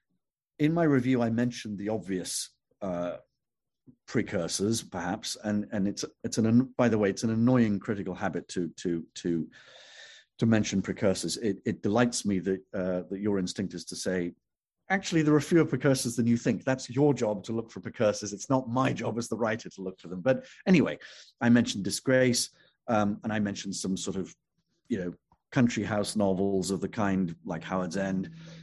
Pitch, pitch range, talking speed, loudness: 105 Hz, 95-120 Hz, 190 wpm, -29 LUFS